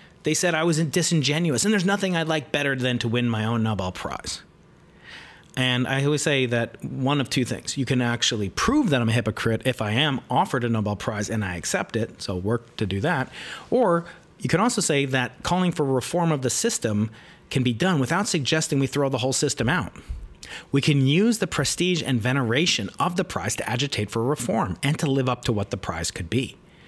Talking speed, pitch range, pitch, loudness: 220 wpm, 120-160 Hz, 135 Hz, -24 LUFS